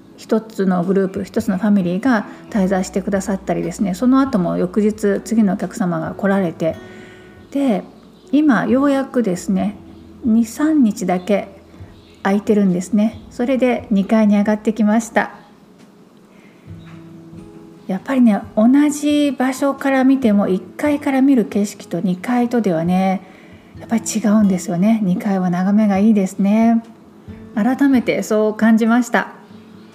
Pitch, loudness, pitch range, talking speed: 210 Hz, -17 LUFS, 195-235 Hz, 275 characters per minute